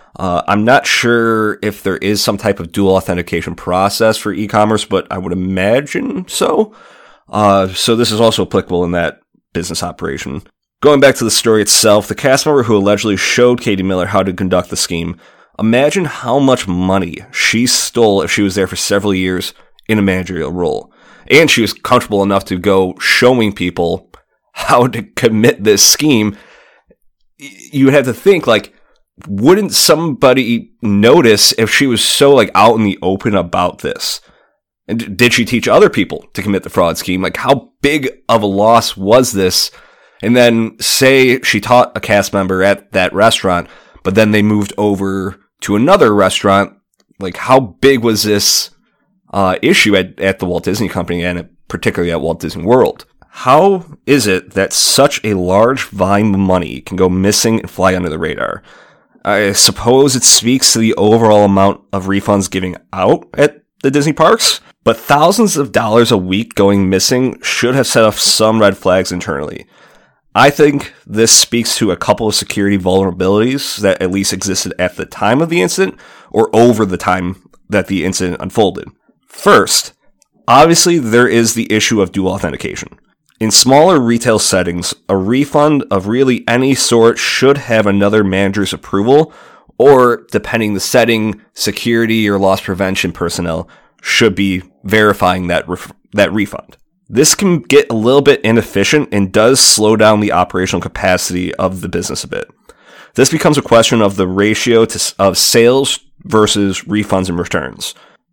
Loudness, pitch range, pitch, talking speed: -12 LUFS, 95-120 Hz, 105 Hz, 170 wpm